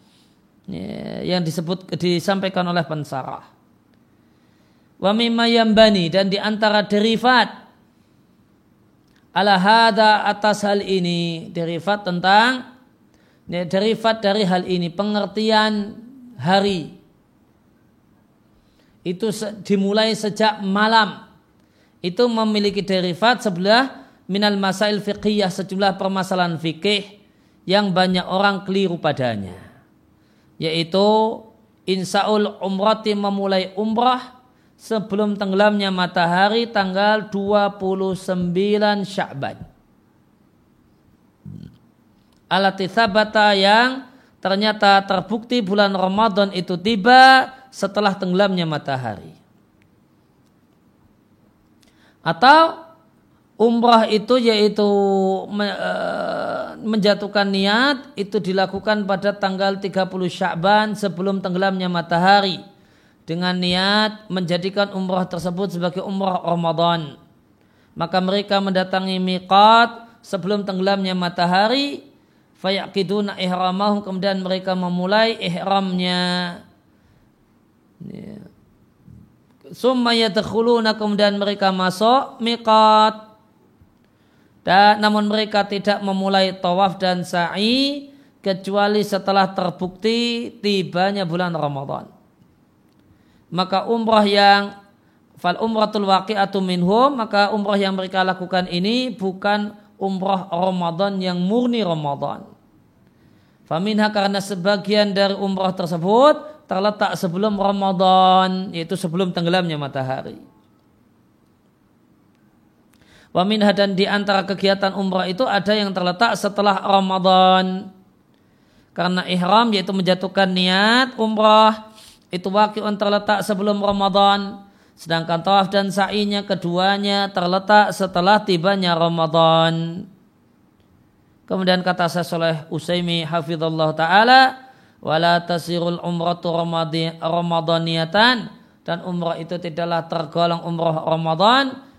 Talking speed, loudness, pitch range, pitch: 85 wpm, -18 LUFS, 180-210 Hz, 195 Hz